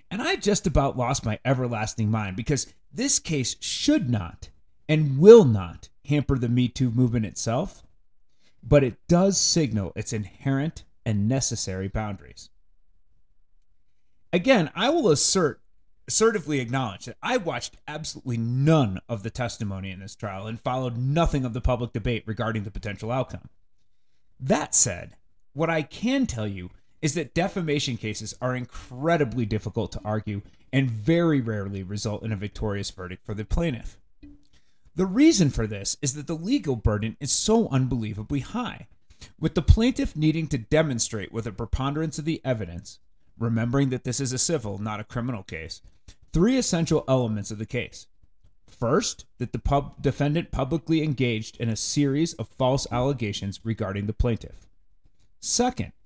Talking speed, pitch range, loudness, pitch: 155 wpm, 105-145 Hz, -25 LUFS, 120 Hz